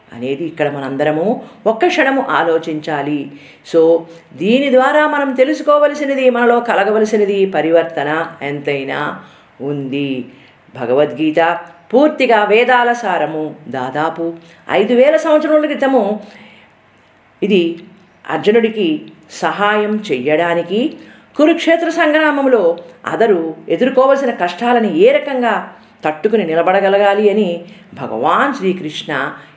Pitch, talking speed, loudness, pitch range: 200 Hz, 85 wpm, -14 LUFS, 160-255 Hz